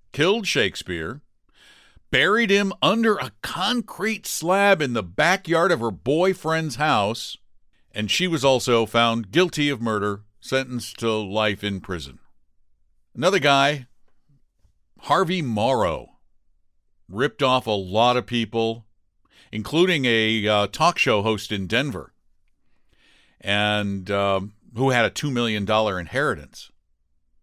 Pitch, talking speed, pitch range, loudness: 115 Hz, 120 wpm, 100-145 Hz, -22 LUFS